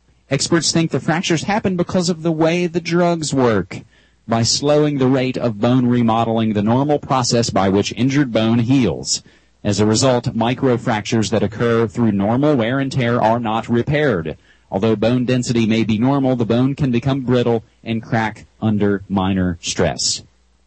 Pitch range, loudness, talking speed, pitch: 110-135 Hz, -17 LUFS, 165 wpm, 120 Hz